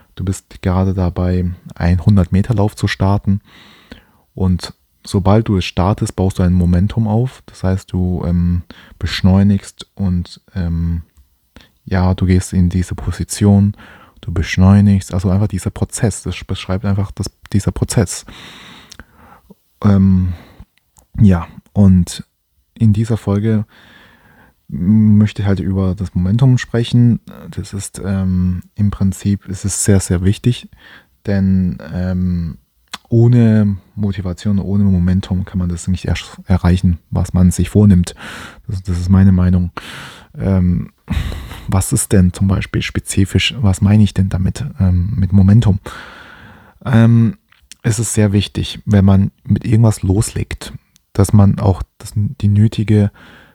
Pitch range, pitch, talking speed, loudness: 90-105 Hz, 95 Hz, 130 wpm, -15 LUFS